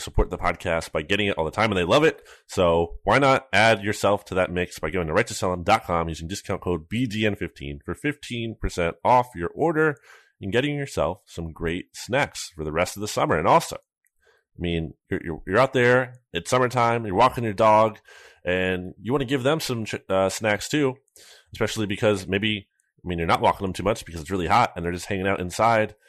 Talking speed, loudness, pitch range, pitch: 215 wpm, -23 LUFS, 90-115 Hz, 100 Hz